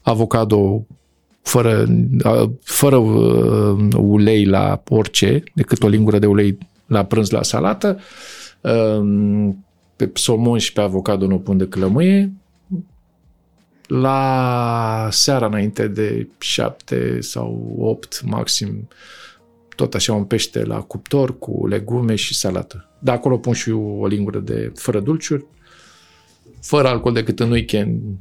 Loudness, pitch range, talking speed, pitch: -17 LUFS, 100-125 Hz, 120 wpm, 110 Hz